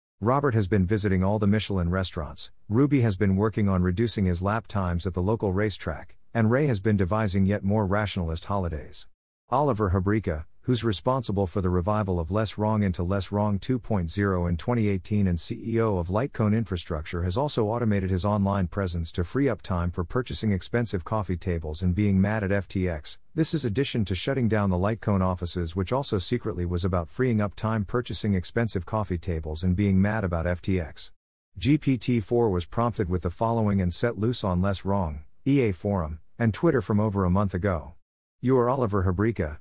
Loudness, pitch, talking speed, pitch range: -26 LUFS, 100 Hz, 185 wpm, 90-110 Hz